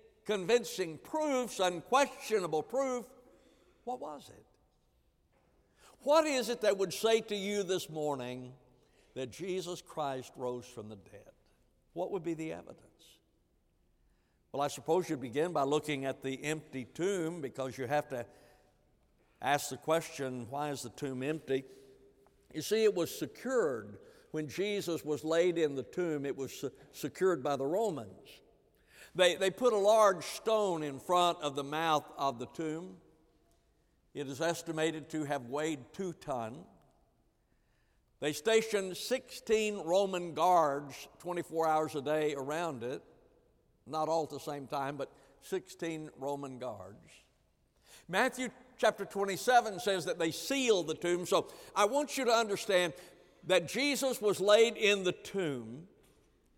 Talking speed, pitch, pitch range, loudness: 145 wpm, 165 Hz, 140-200 Hz, -33 LUFS